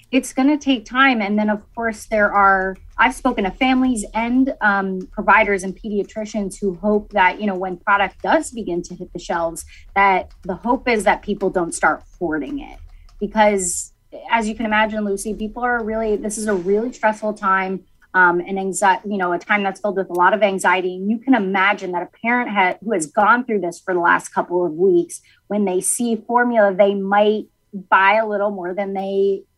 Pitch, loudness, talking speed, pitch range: 205 Hz, -18 LUFS, 210 wpm, 190-225 Hz